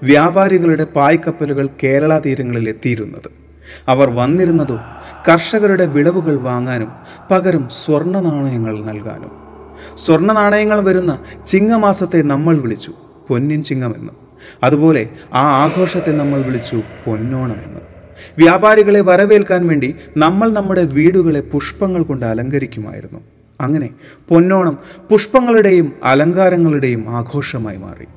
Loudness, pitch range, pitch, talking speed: -13 LUFS, 125-180 Hz, 150 Hz, 90 wpm